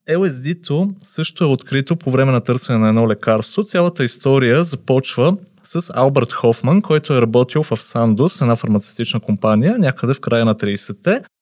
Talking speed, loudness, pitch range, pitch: 160 wpm, -16 LUFS, 115-165 Hz, 130 Hz